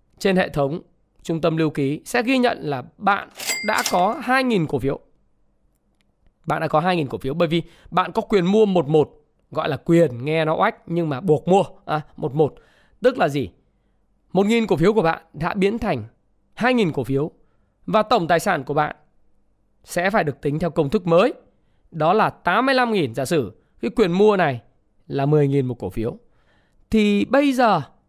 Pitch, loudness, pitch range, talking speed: 170 Hz, -21 LUFS, 145-210 Hz, 195 wpm